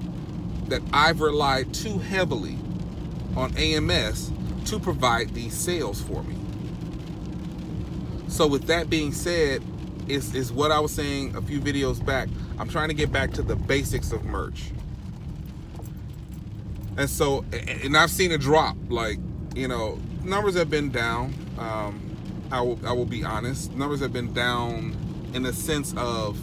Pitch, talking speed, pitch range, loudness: 135 Hz, 150 wpm, 115-150 Hz, -26 LUFS